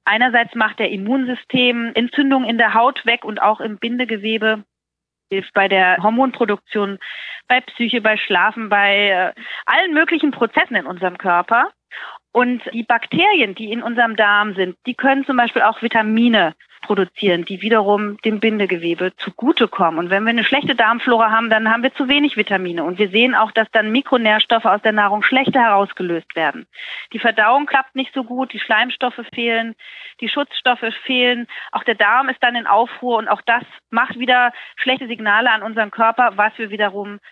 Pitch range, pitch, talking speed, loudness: 210-250 Hz, 230 Hz, 170 wpm, -16 LUFS